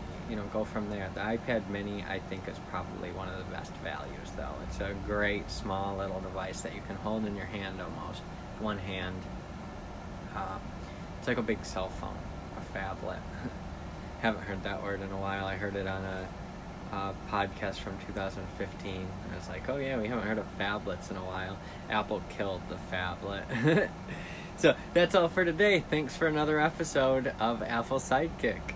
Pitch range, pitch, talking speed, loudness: 95-110 Hz, 100 Hz, 185 wpm, -34 LUFS